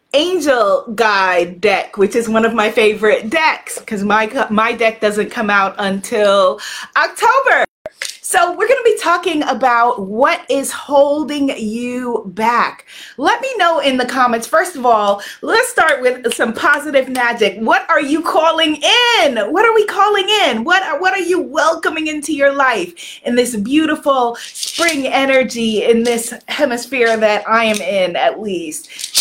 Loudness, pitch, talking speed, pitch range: -14 LUFS, 270 Hz, 160 wpm, 230-325 Hz